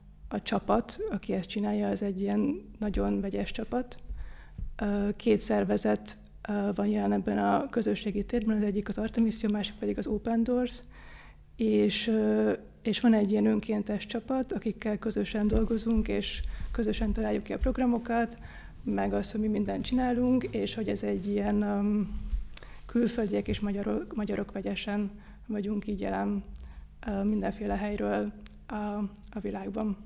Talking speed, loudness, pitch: 140 wpm, -30 LUFS, 210 Hz